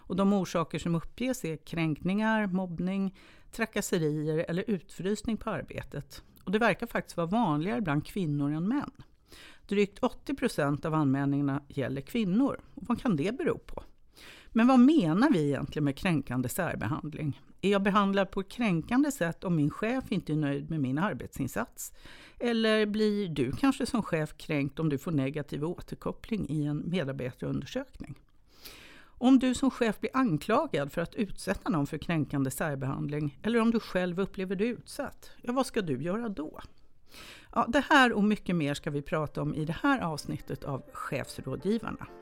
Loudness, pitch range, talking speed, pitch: -30 LUFS, 150-225 Hz, 165 wpm, 185 Hz